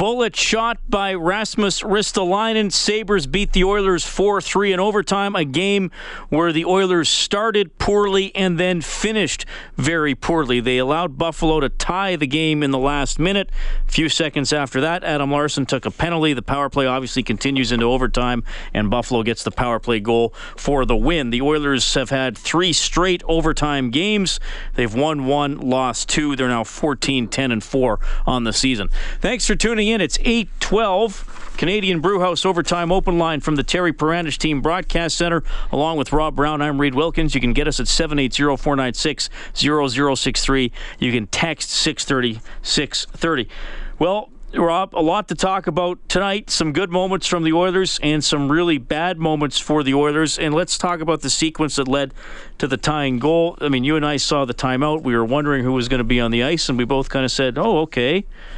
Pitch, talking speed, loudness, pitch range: 155 Hz, 185 wpm, -19 LUFS, 135-180 Hz